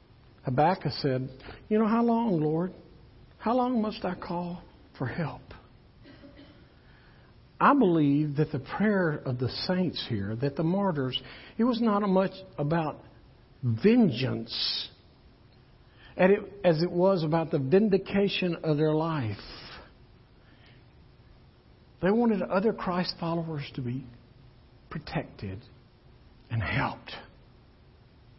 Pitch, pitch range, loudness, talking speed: 155 Hz, 125-190 Hz, -28 LUFS, 110 wpm